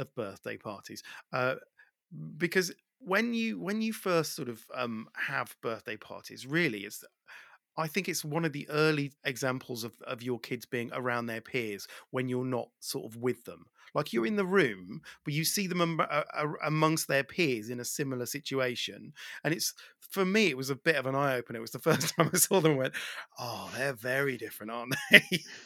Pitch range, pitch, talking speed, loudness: 120-165 Hz, 140 Hz, 200 wpm, -31 LUFS